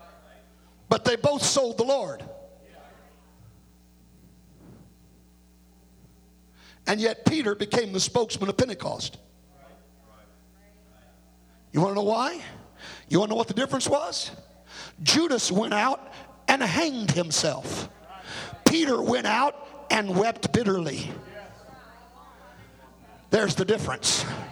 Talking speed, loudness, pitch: 105 wpm, -25 LUFS, 185 Hz